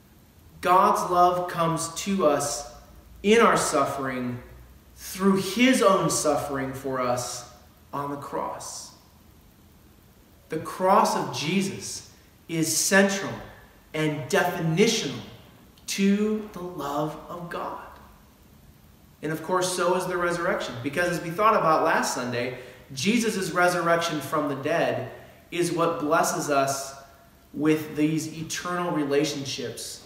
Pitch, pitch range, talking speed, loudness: 155 Hz, 130-180 Hz, 115 wpm, -25 LUFS